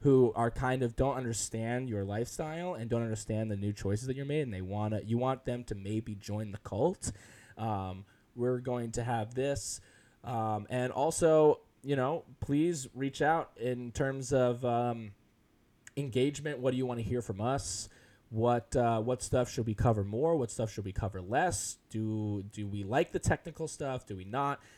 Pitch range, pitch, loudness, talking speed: 110-130 Hz, 120 Hz, -33 LUFS, 190 wpm